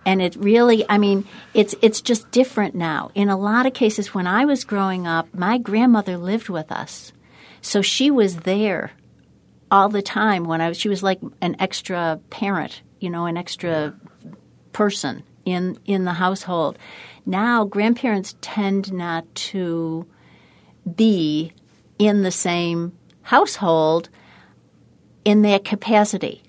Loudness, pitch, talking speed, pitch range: -20 LUFS, 195 Hz, 145 wpm, 175-210 Hz